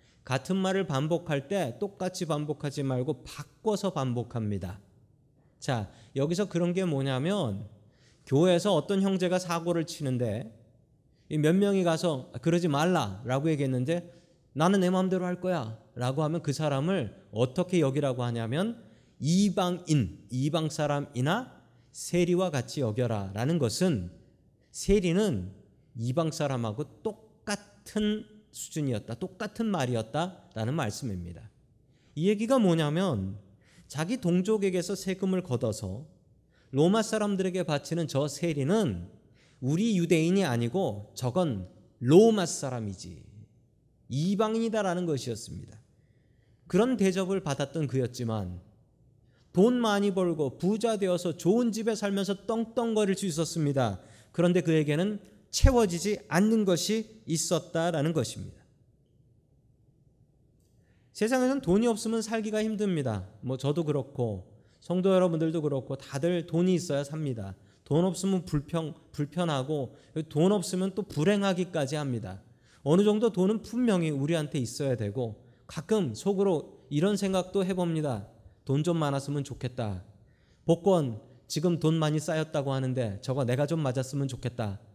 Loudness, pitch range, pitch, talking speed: -29 LUFS, 125-185 Hz, 150 Hz, 290 characters per minute